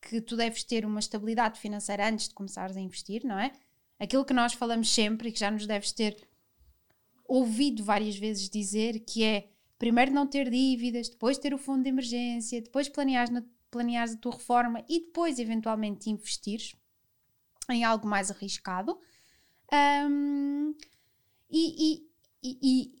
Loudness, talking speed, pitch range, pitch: -30 LUFS, 155 wpm, 215-265 Hz, 235 Hz